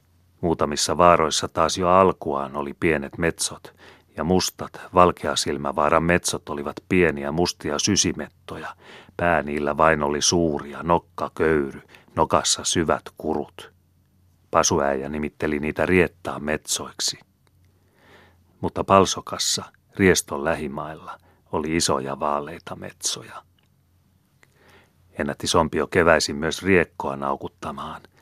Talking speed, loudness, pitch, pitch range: 95 wpm, -22 LUFS, 80 Hz, 75-90 Hz